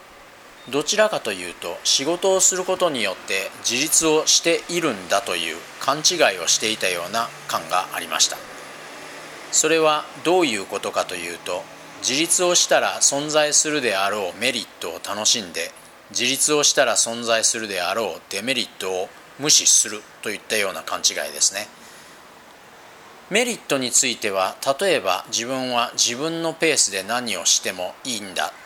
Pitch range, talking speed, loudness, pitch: 130-175 Hz, 320 characters per minute, -20 LUFS, 155 Hz